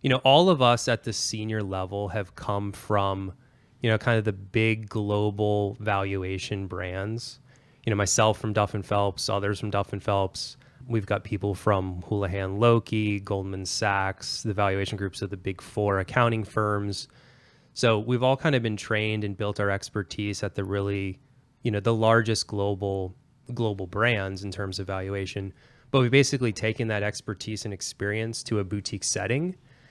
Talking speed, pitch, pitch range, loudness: 175 wpm, 105 Hz, 100-120 Hz, -27 LUFS